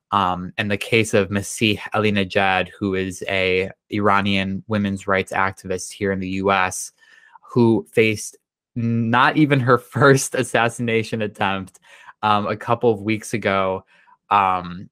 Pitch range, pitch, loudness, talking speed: 95-115 Hz, 105 Hz, -20 LUFS, 135 wpm